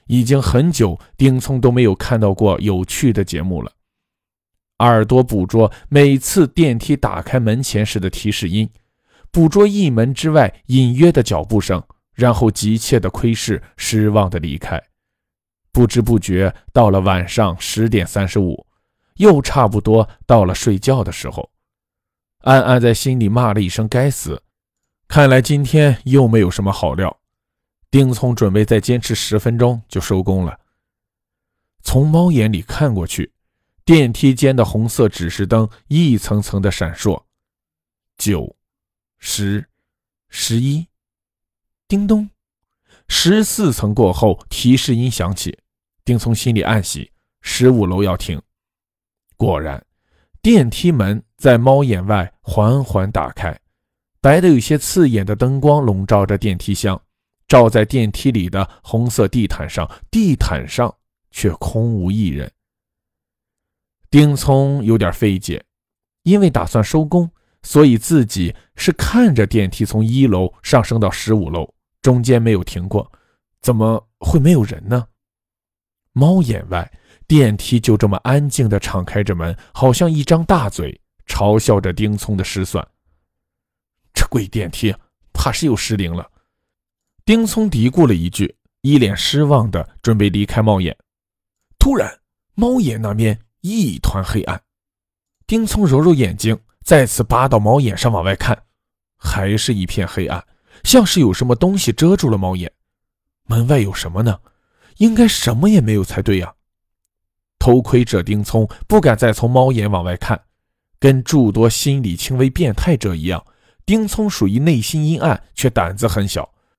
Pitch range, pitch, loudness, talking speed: 95-130 Hz, 110 Hz, -15 LUFS, 215 characters per minute